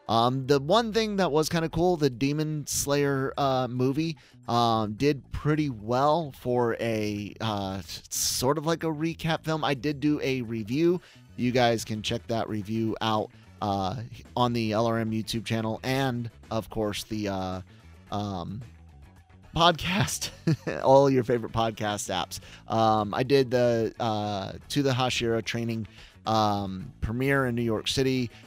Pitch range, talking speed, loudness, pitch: 110-140 Hz, 150 wpm, -27 LUFS, 115 Hz